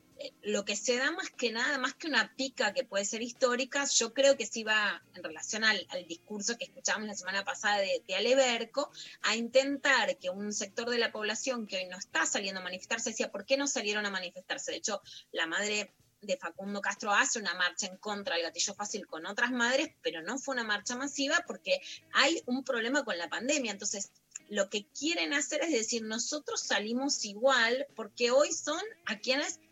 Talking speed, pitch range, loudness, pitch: 205 wpm, 205-275 Hz, -31 LUFS, 235 Hz